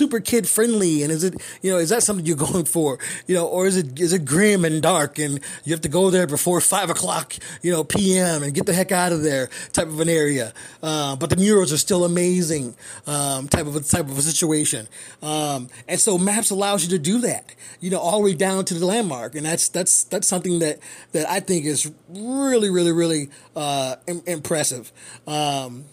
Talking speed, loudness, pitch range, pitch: 220 wpm, -20 LUFS, 150-185 Hz, 170 Hz